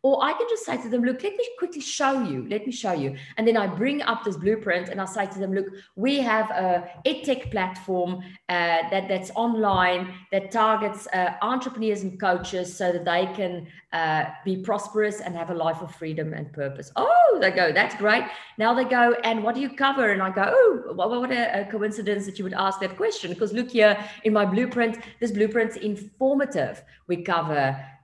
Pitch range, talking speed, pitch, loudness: 180-235 Hz, 210 wpm, 205 Hz, -24 LUFS